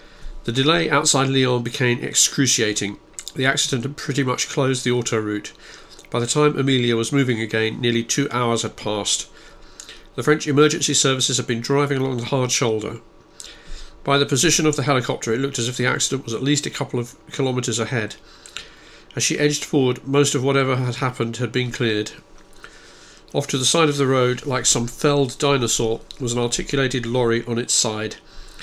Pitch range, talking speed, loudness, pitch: 120-140 Hz, 185 wpm, -20 LUFS, 130 Hz